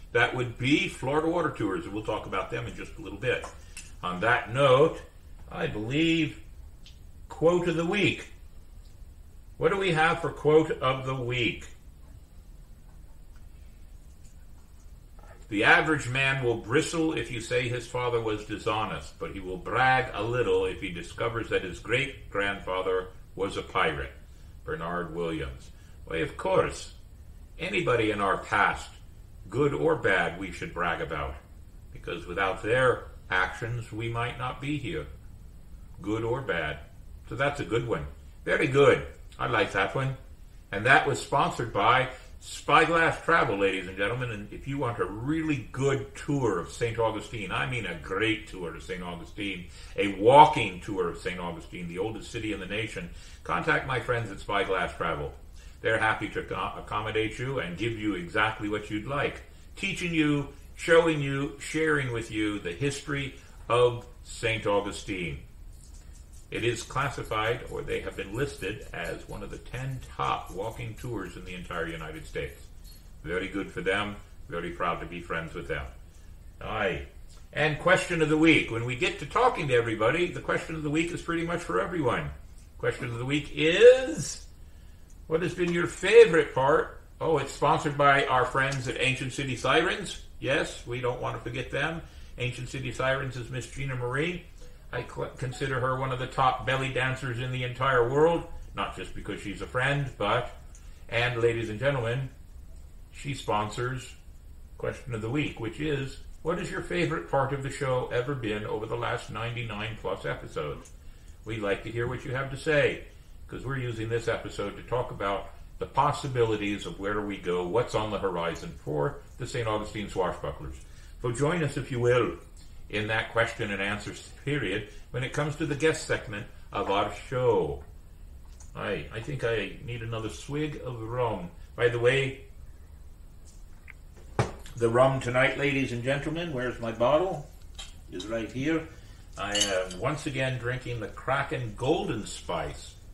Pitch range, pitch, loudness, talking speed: 85-135 Hz, 115 Hz, -28 LUFS, 165 wpm